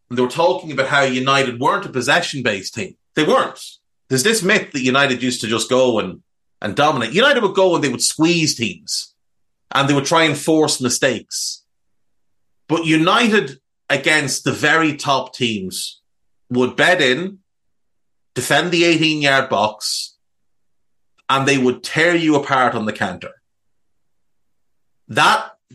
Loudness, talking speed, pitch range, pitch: -17 LUFS, 155 wpm, 125-160 Hz, 135 Hz